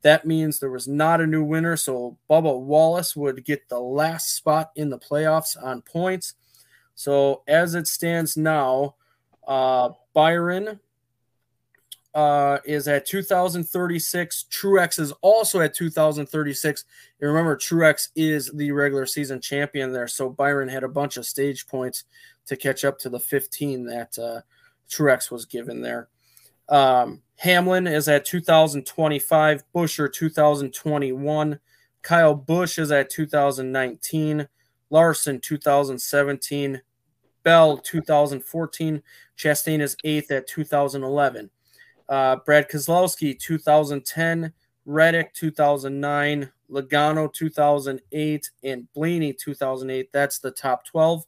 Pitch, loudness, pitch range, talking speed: 145 Hz, -22 LUFS, 135-160 Hz, 120 wpm